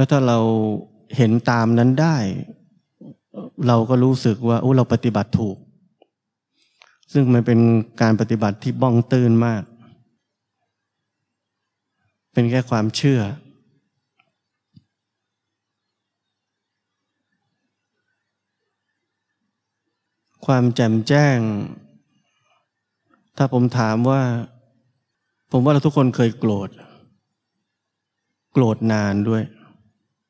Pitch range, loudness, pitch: 110-130 Hz, -19 LUFS, 115 Hz